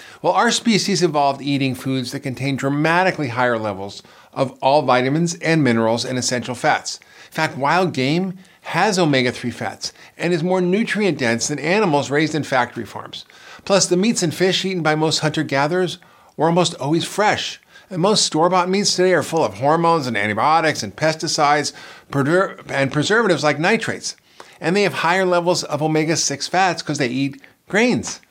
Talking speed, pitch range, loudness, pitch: 175 wpm, 135-180 Hz, -18 LUFS, 155 Hz